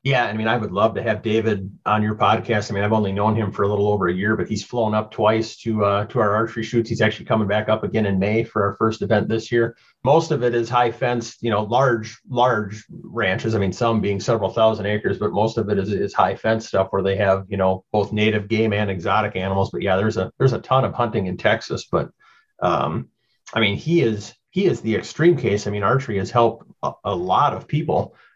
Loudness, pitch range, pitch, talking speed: -21 LUFS, 105-115 Hz, 110 Hz, 250 wpm